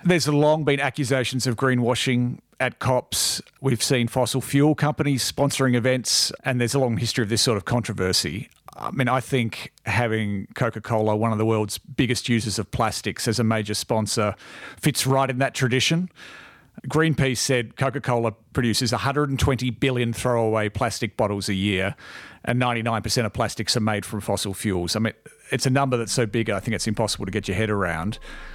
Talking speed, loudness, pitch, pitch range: 185 wpm, -23 LUFS, 120 Hz, 110-135 Hz